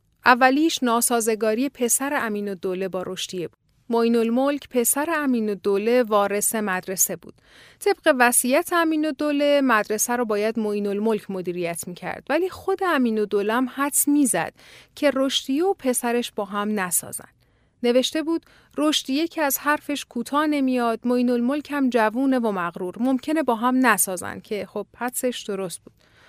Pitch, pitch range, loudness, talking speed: 240 Hz, 210-280 Hz, -22 LUFS, 155 wpm